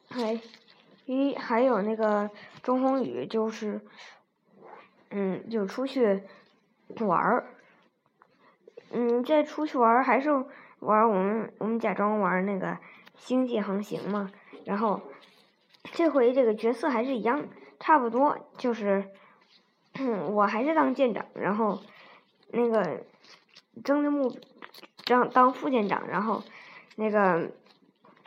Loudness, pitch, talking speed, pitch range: -27 LUFS, 230 Hz, 170 characters per minute, 205-260 Hz